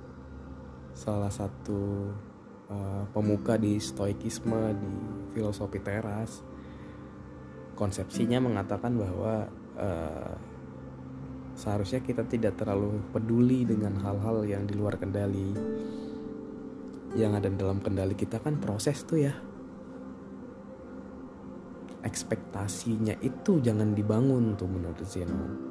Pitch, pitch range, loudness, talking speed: 100 Hz, 90-110 Hz, -31 LUFS, 95 wpm